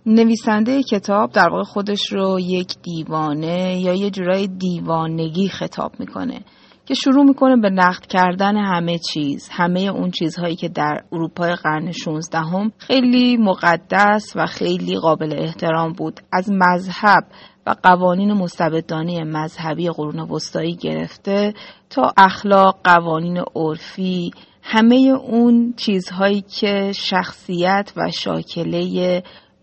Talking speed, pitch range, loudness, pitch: 115 wpm, 165-200 Hz, -18 LUFS, 180 Hz